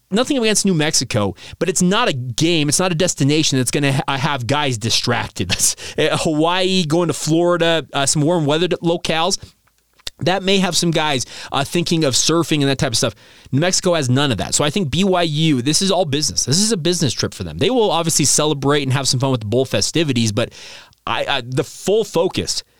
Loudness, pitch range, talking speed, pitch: -17 LUFS, 135-175 Hz, 215 wpm, 155 Hz